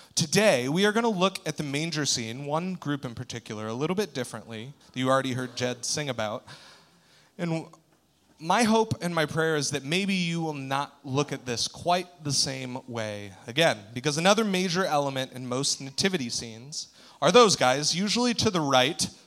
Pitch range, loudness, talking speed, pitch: 125-180 Hz, -26 LUFS, 185 wpm, 145 Hz